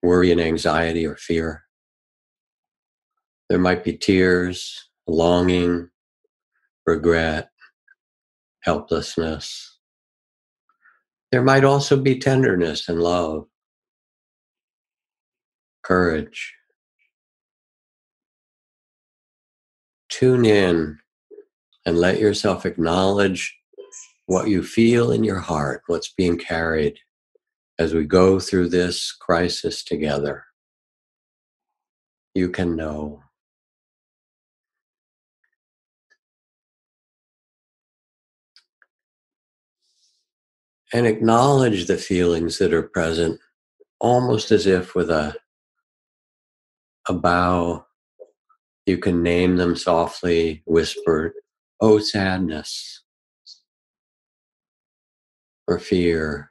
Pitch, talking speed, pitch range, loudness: 90 Hz, 75 wpm, 80-110 Hz, -20 LUFS